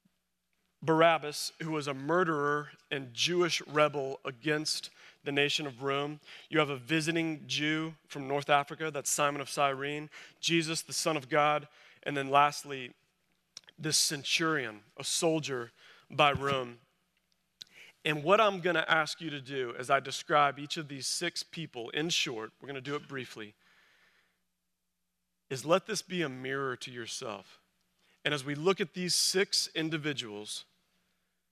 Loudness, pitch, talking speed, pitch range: -31 LUFS, 150 Hz, 150 wpm, 140-165 Hz